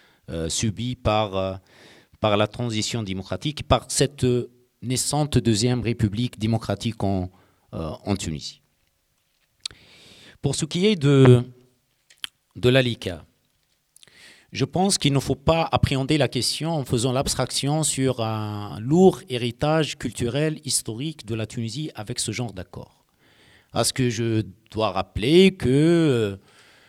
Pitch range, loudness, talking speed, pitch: 110-135 Hz, -23 LUFS, 130 wpm, 125 Hz